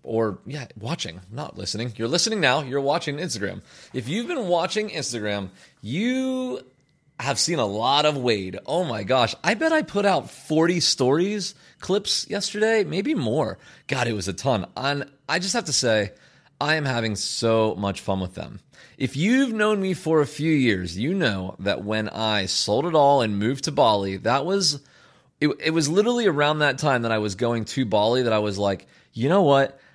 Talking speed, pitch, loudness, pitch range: 195 wpm, 140 Hz, -23 LUFS, 110-180 Hz